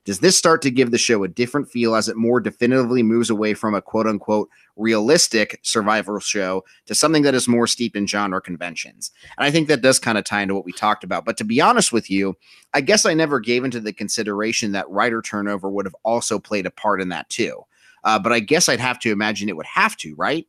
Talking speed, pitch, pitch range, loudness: 245 wpm, 110 Hz, 105-120 Hz, -19 LUFS